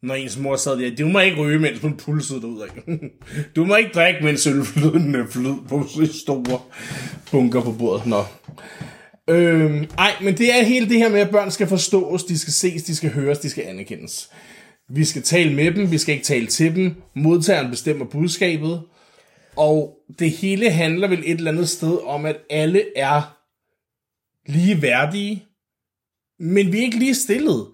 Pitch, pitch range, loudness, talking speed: 155 Hz, 145-185 Hz, -19 LUFS, 175 wpm